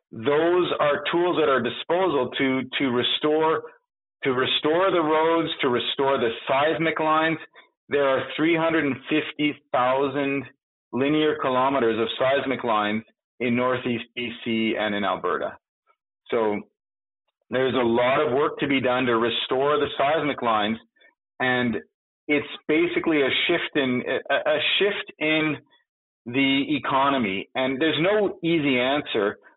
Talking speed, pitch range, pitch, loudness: 135 wpm, 125-155 Hz, 140 Hz, -23 LUFS